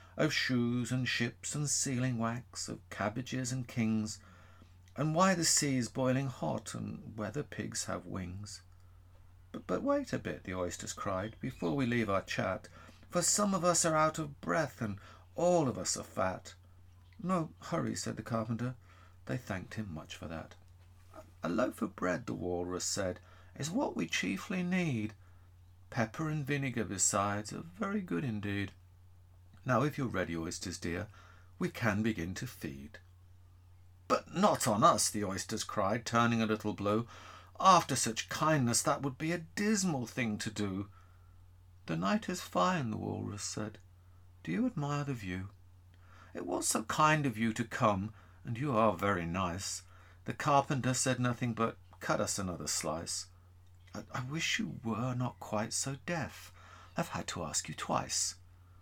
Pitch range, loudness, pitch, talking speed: 90-130 Hz, -34 LUFS, 105 Hz, 165 wpm